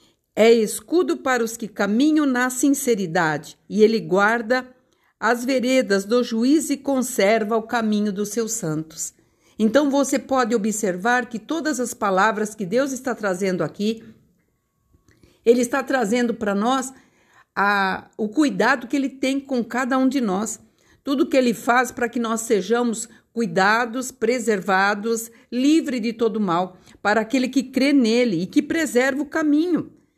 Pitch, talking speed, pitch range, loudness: 240 Hz, 150 wpm, 215-265 Hz, -21 LUFS